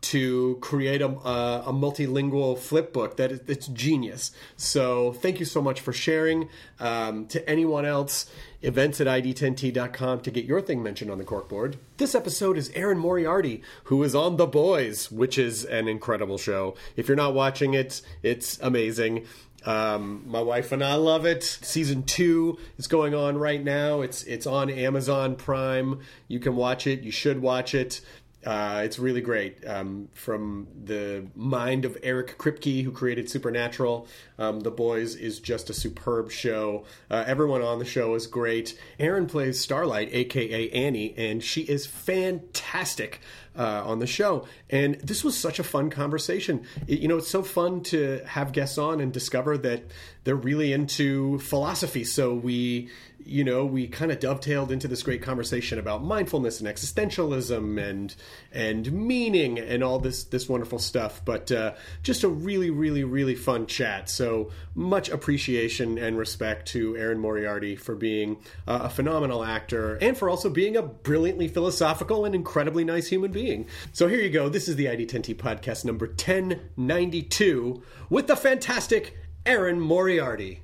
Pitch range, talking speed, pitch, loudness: 115-150 Hz, 165 wpm, 130 Hz, -26 LUFS